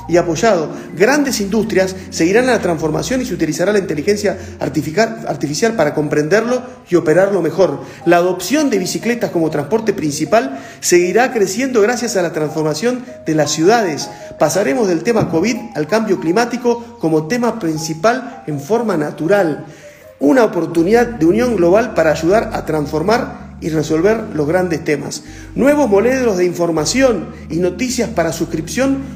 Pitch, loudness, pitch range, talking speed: 190 Hz, -15 LUFS, 160-235 Hz, 145 wpm